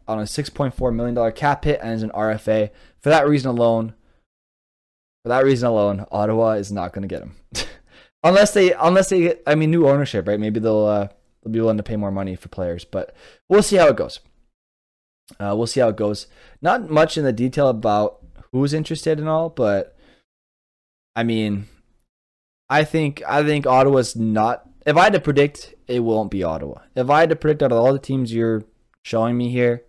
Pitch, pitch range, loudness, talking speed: 115 Hz, 105-145 Hz, -19 LUFS, 210 wpm